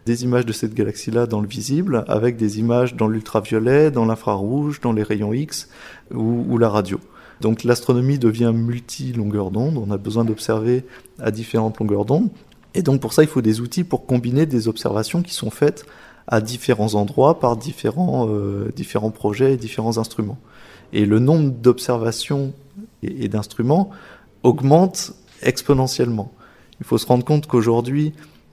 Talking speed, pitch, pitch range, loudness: 160 wpm, 120 Hz, 110-135 Hz, -20 LUFS